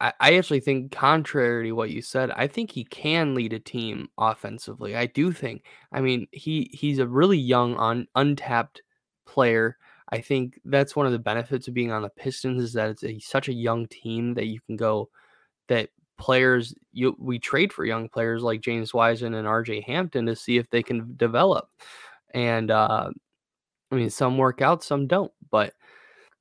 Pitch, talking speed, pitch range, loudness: 120 Hz, 190 wpm, 115-135 Hz, -25 LUFS